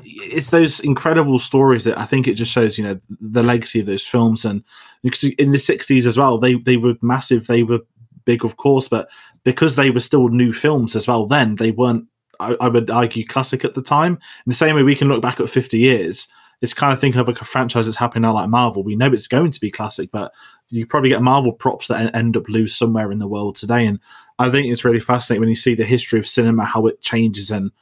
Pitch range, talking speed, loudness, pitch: 115-130 Hz, 250 wpm, -17 LUFS, 120 Hz